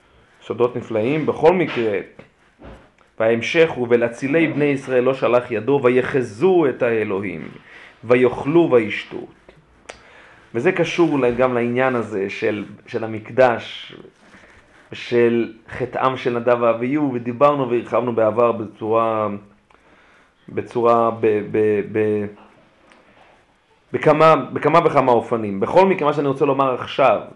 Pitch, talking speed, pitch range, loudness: 120 Hz, 110 wpm, 110-135 Hz, -18 LUFS